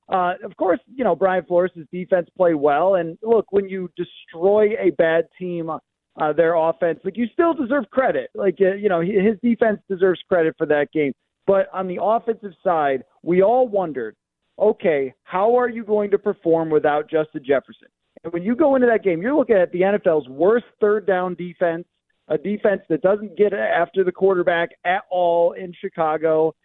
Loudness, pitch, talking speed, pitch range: -20 LUFS, 185 Hz, 190 wpm, 165-205 Hz